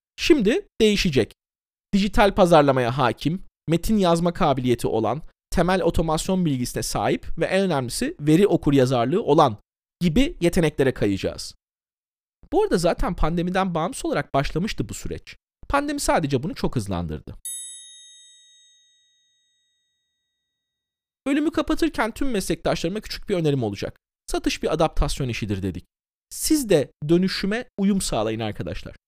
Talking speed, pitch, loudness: 115 wpm, 175 Hz, -22 LUFS